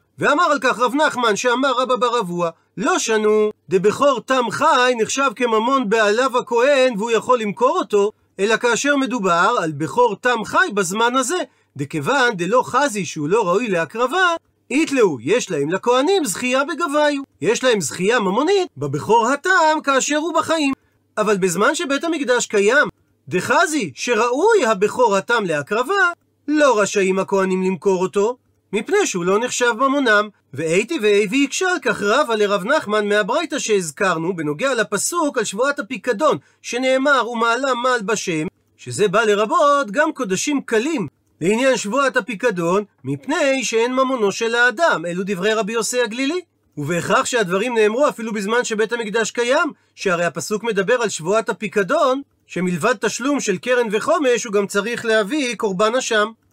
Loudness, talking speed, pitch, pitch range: -18 LUFS, 145 wpm, 235 Hz, 205-275 Hz